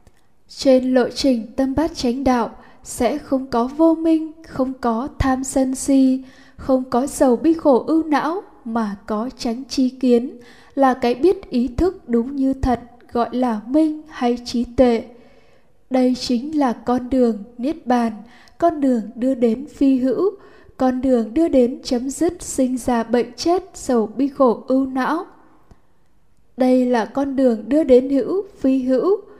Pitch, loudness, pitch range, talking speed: 260 Hz, -19 LUFS, 245-285 Hz, 165 wpm